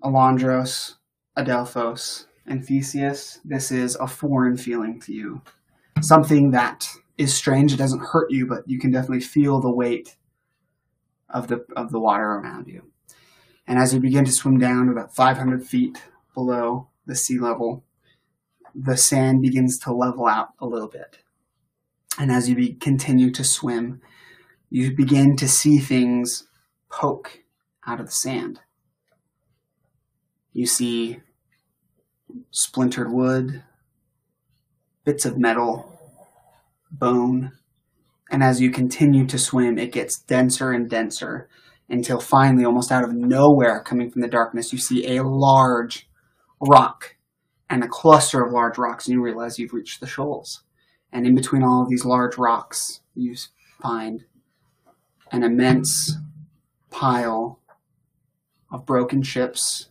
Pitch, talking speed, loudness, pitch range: 125 Hz, 135 wpm, -20 LUFS, 120-135 Hz